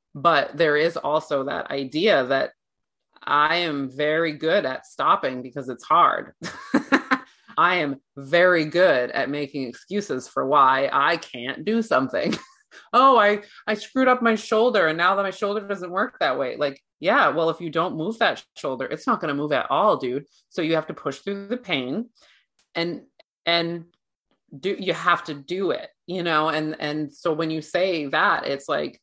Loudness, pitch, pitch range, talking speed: -22 LUFS, 170 Hz, 150-200 Hz, 185 wpm